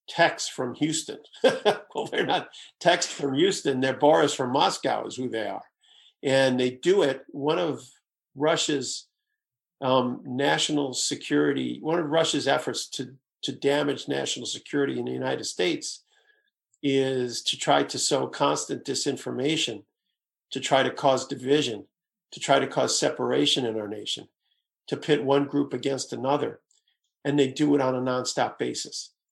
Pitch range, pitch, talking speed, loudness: 130-150 Hz, 140 Hz, 150 wpm, -26 LUFS